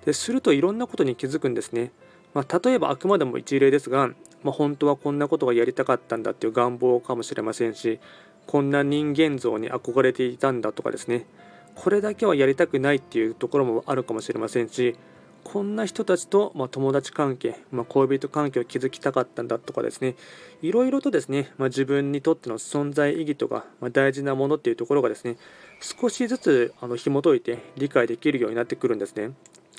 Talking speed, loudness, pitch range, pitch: 430 characters per minute, -24 LUFS, 125-160 Hz, 140 Hz